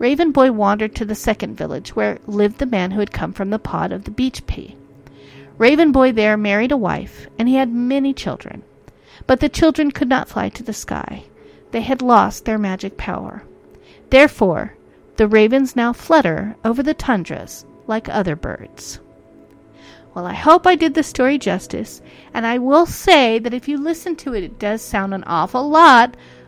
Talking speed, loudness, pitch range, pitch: 185 wpm, -17 LUFS, 215-285 Hz, 245 Hz